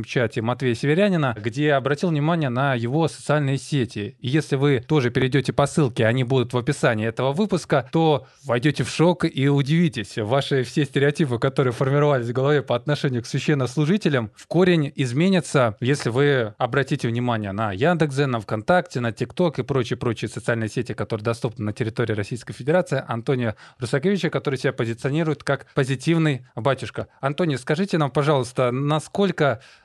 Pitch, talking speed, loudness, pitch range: 140 Hz, 155 wpm, -22 LUFS, 120-150 Hz